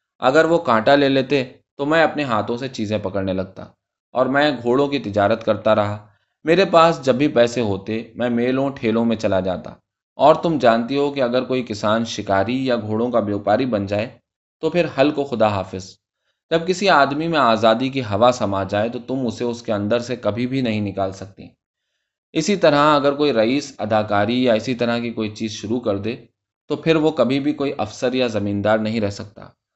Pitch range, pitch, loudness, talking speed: 105-140 Hz, 120 Hz, -19 LUFS, 205 wpm